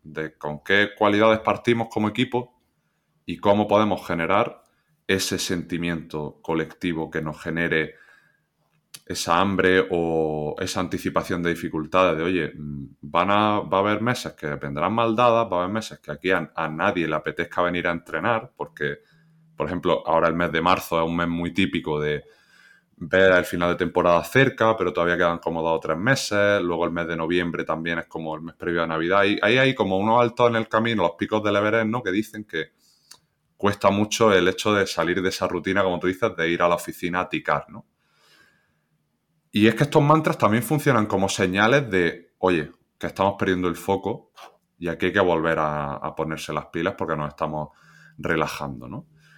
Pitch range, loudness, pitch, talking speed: 80-105 Hz, -23 LUFS, 90 Hz, 190 wpm